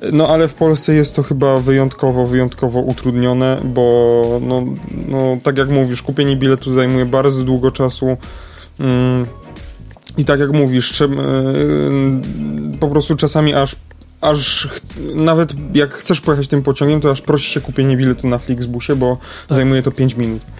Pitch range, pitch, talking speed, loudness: 125-145 Hz, 130 Hz, 155 wpm, -15 LUFS